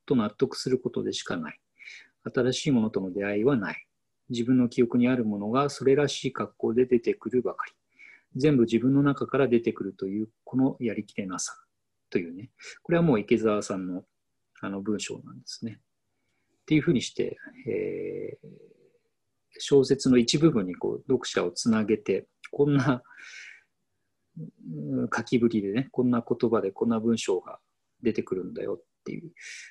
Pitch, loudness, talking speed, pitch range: 125 Hz, -27 LUFS, 315 characters per minute, 115-145 Hz